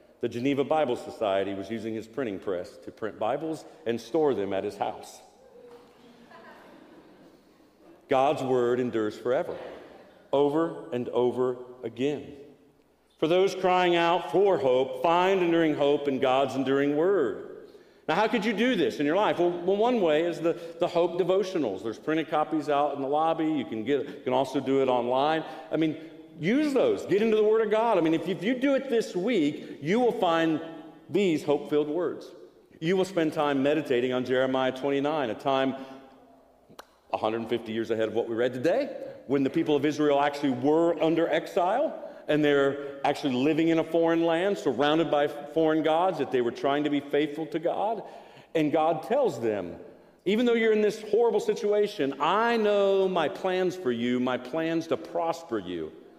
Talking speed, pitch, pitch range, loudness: 180 wpm, 160 Hz, 135-195 Hz, -27 LUFS